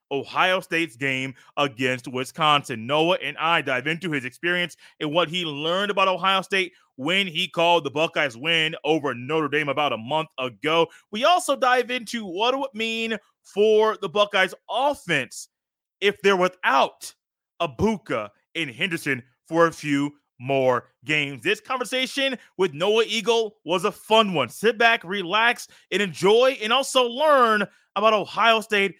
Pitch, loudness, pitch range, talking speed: 180 Hz, -22 LUFS, 155-220 Hz, 160 wpm